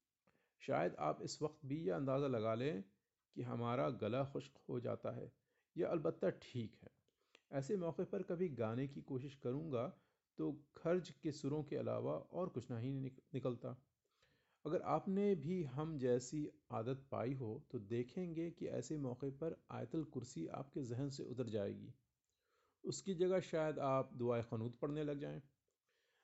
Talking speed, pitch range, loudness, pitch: 155 wpm, 125-160 Hz, -43 LUFS, 140 Hz